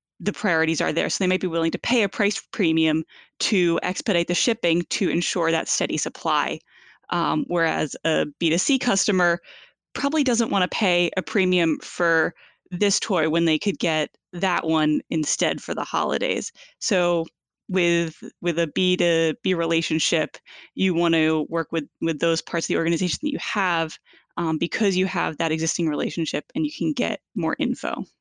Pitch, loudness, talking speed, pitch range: 170 Hz, -23 LUFS, 170 wpm, 165-190 Hz